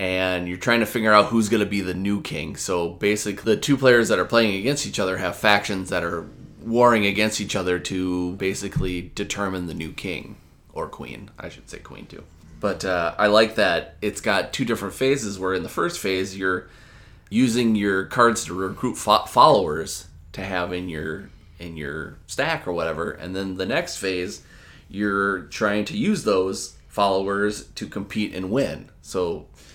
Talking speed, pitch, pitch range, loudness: 190 wpm, 100 Hz, 90-110 Hz, -22 LUFS